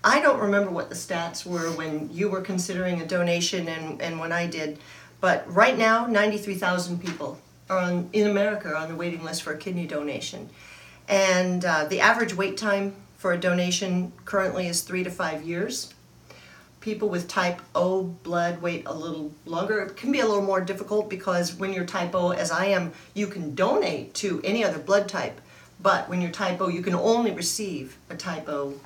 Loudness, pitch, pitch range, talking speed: -26 LUFS, 180 Hz, 165-195 Hz, 200 wpm